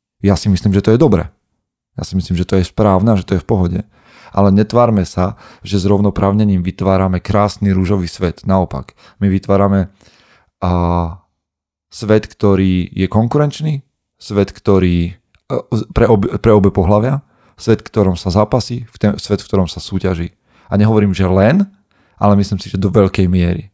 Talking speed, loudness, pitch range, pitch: 165 wpm, -15 LUFS, 95-105 Hz, 100 Hz